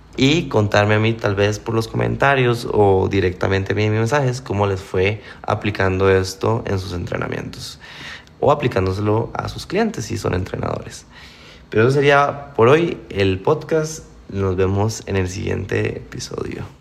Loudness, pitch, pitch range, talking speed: -19 LUFS, 105 Hz, 95-120 Hz, 155 wpm